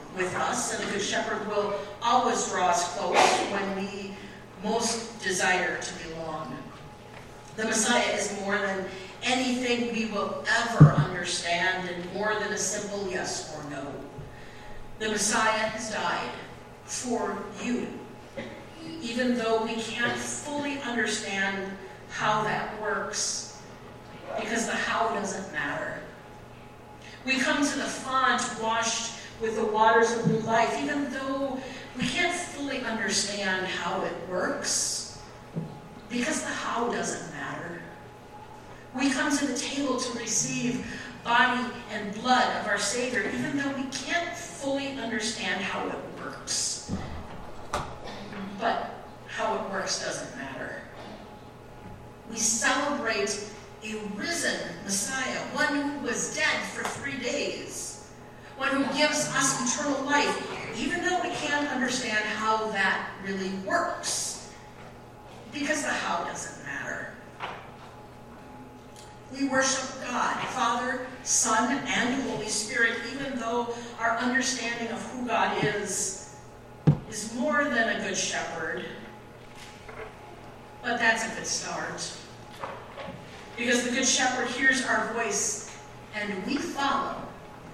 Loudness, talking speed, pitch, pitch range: -28 LUFS, 120 wpm, 230 Hz, 205-265 Hz